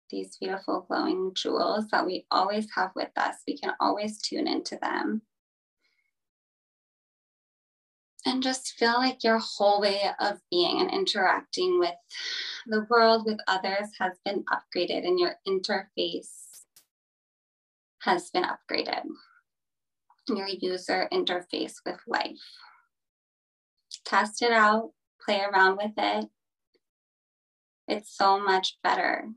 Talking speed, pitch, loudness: 115 wpm, 235 Hz, -27 LUFS